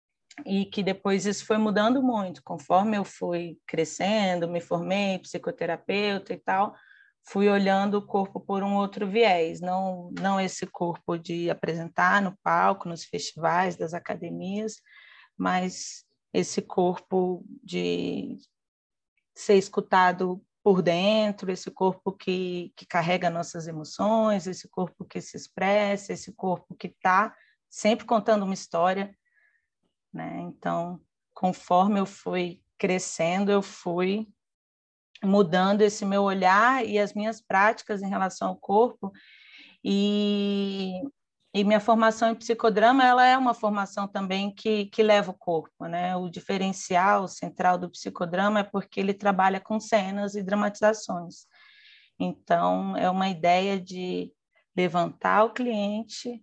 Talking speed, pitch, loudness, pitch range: 130 wpm, 195 Hz, -26 LUFS, 180-210 Hz